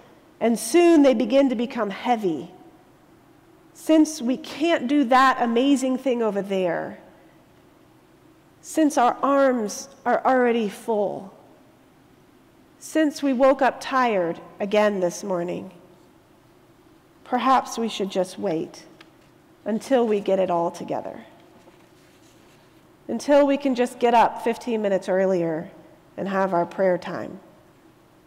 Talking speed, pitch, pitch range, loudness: 115 wpm, 240 Hz, 195-270 Hz, -22 LUFS